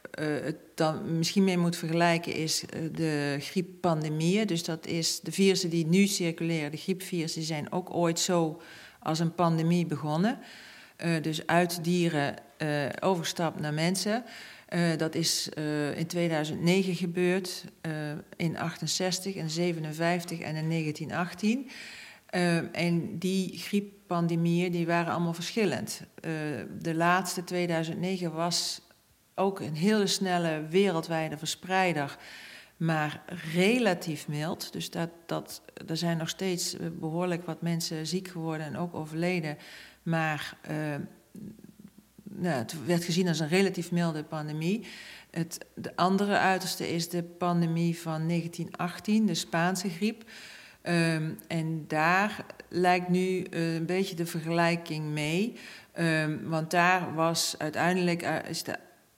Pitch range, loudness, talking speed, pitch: 160-185 Hz, -29 LUFS, 130 wpm, 170 Hz